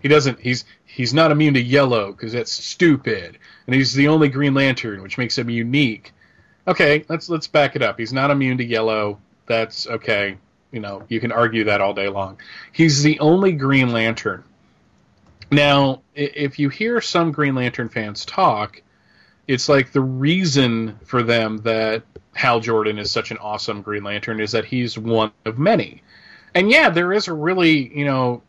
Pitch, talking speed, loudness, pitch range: 125 Hz, 180 wpm, -18 LUFS, 110-145 Hz